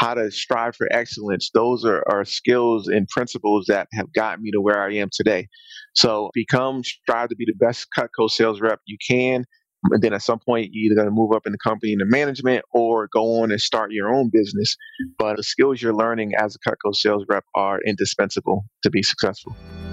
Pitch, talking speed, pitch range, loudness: 110 Hz, 215 wpm, 105-125 Hz, -21 LUFS